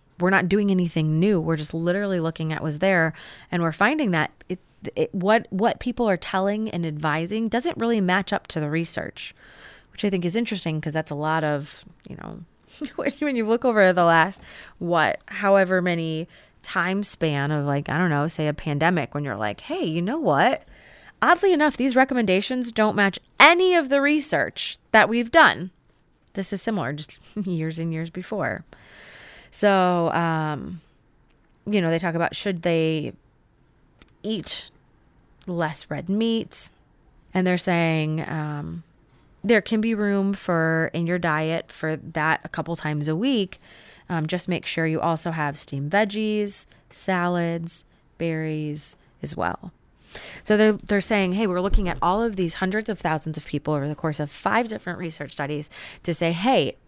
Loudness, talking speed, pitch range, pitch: -23 LUFS, 170 wpm, 155-205 Hz, 175 Hz